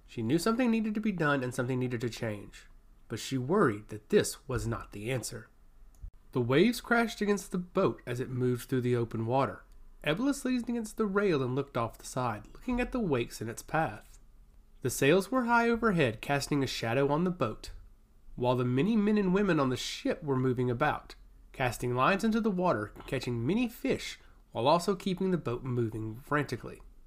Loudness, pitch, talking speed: -31 LUFS, 130 Hz, 195 wpm